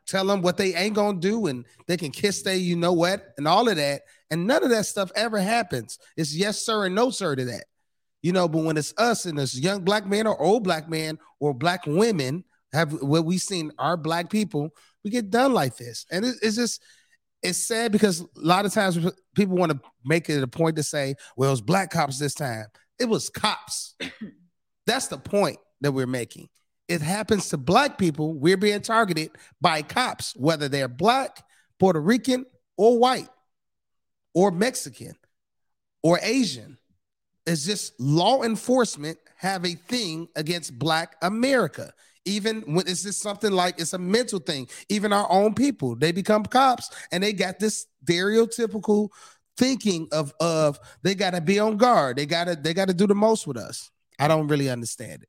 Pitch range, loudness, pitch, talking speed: 155-215 Hz, -24 LUFS, 180 Hz, 190 wpm